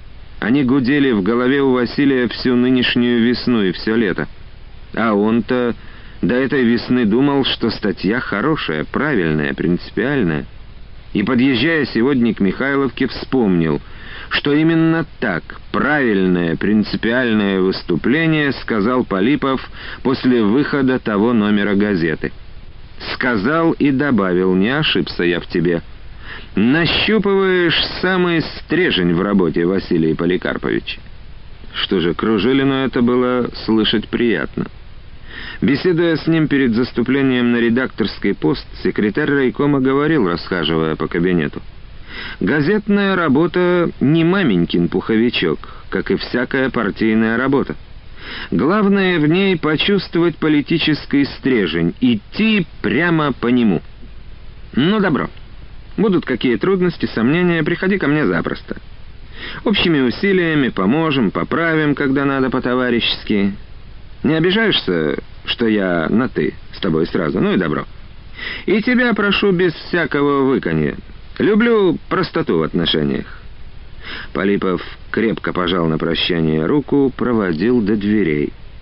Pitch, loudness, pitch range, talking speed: 125 Hz, -16 LUFS, 100-155 Hz, 110 wpm